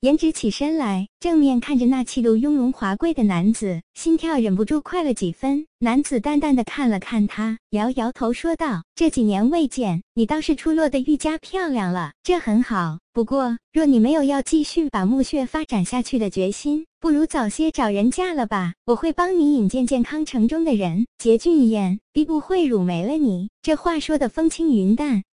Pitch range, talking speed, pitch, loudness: 220-305 Hz, 280 characters per minute, 255 Hz, -21 LUFS